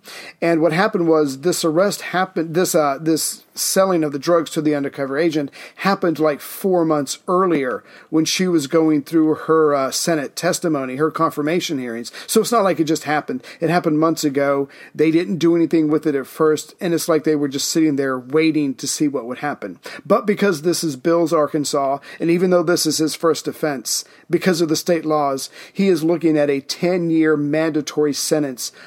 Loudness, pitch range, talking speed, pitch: -19 LUFS, 150-175 Hz, 195 wpm, 160 Hz